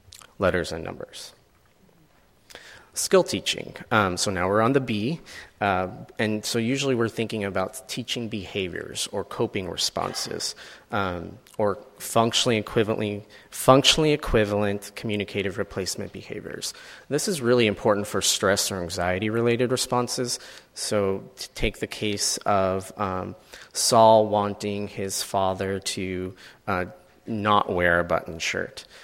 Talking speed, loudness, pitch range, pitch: 125 wpm, -24 LUFS, 95-120 Hz, 105 Hz